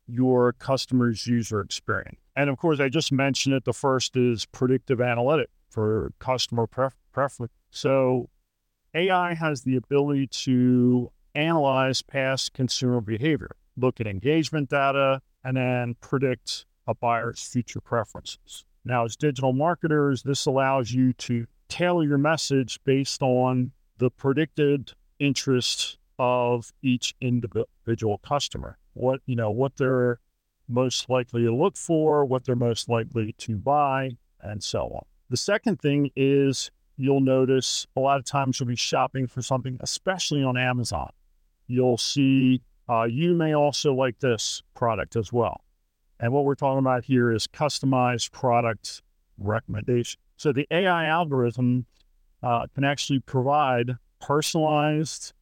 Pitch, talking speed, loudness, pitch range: 130 Hz, 140 wpm, -25 LUFS, 120-140 Hz